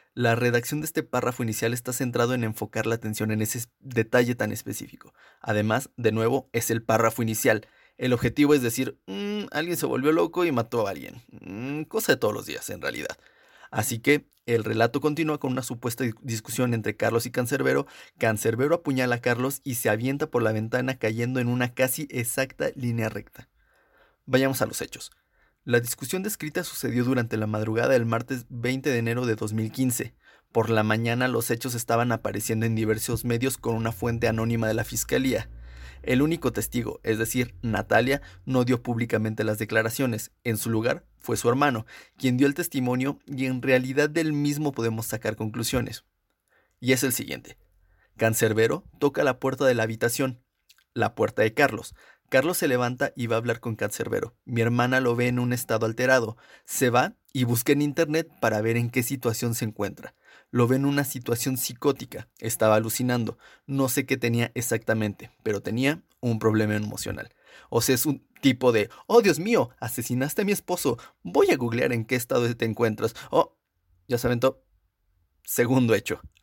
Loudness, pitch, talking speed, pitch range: -26 LUFS, 120 Hz, 180 wpm, 110-130 Hz